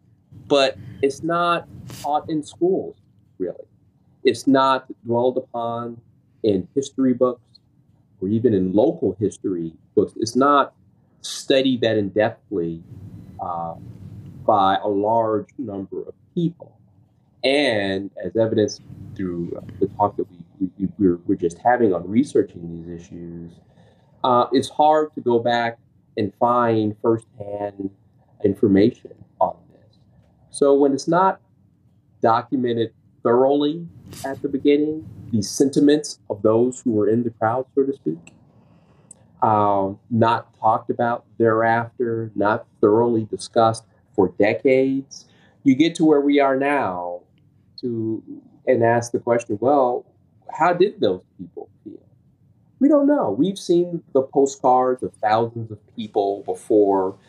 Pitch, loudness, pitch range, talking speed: 120 Hz, -21 LUFS, 105-140 Hz, 130 wpm